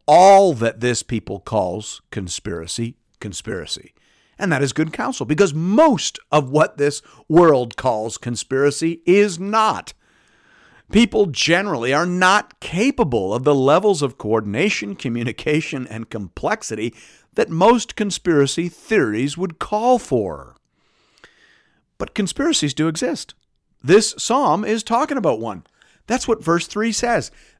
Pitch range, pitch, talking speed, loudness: 125-205 Hz, 160 Hz, 125 wpm, -18 LUFS